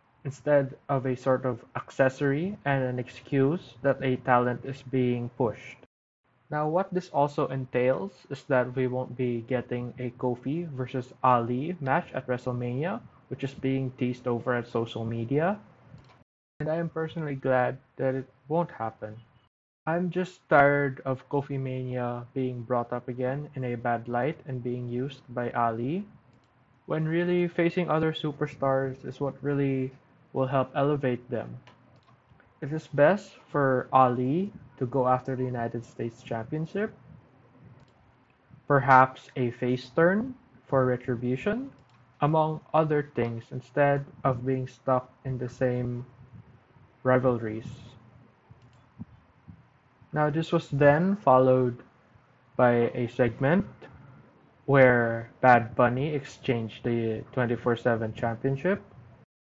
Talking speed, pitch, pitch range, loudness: 125 wpm, 130 Hz, 125-140 Hz, -28 LUFS